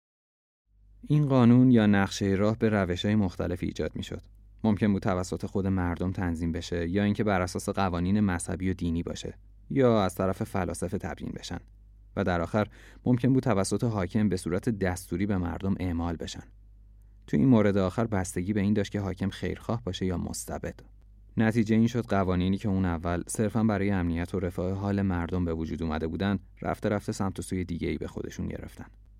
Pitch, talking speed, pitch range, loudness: 95 Hz, 185 wpm, 90-105 Hz, -28 LUFS